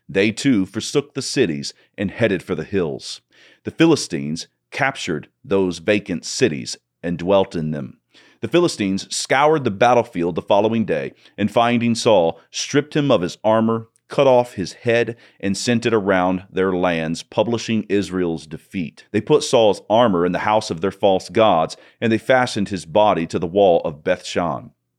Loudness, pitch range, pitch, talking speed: -19 LUFS, 90-120 Hz, 105 Hz, 170 wpm